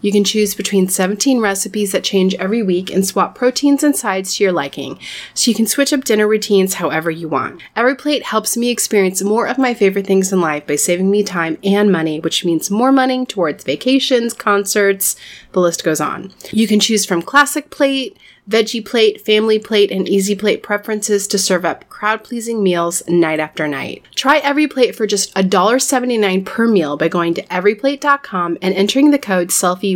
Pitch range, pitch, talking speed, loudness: 185-230 Hz, 205 Hz, 190 wpm, -15 LUFS